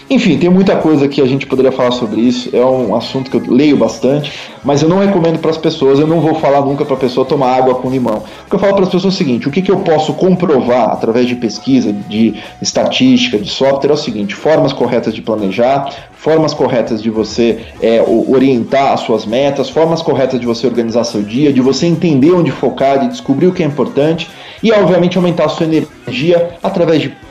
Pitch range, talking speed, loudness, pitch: 130-170 Hz, 225 wpm, -12 LUFS, 140 Hz